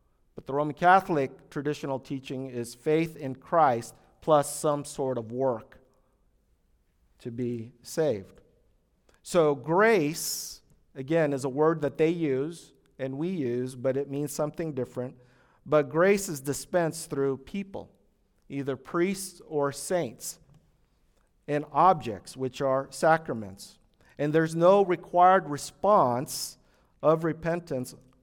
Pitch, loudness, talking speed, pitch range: 145 Hz, -27 LUFS, 120 wpm, 130-160 Hz